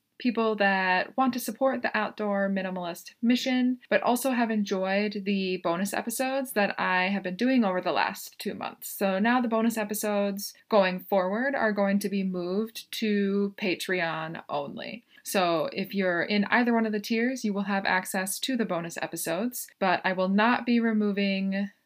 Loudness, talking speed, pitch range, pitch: -27 LUFS, 175 wpm, 190-235 Hz, 205 Hz